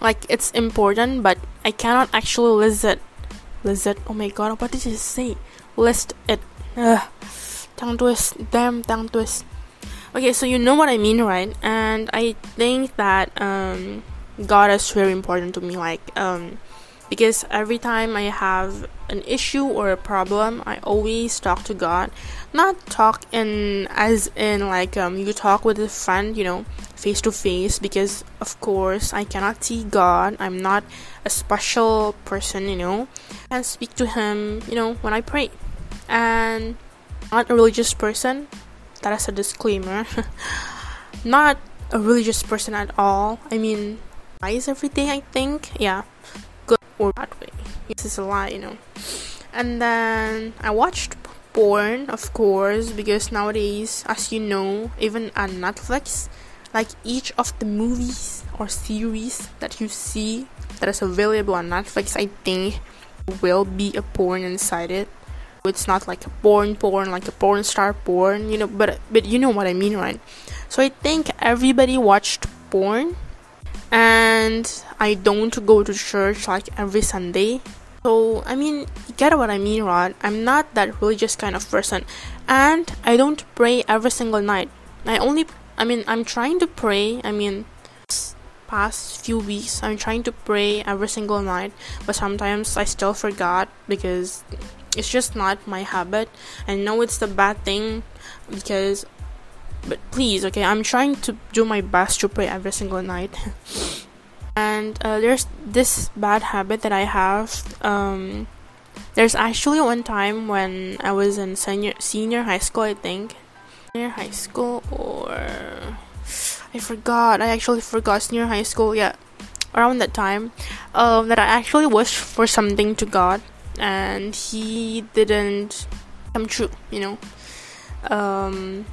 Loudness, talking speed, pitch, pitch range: -21 LUFS, 160 wpm, 215 Hz, 200-230 Hz